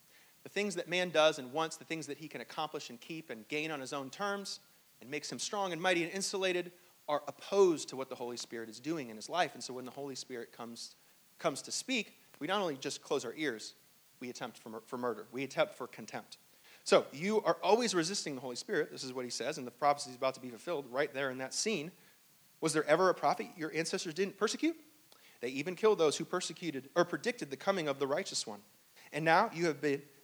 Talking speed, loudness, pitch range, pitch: 240 wpm, -35 LUFS, 130-180 Hz, 155 Hz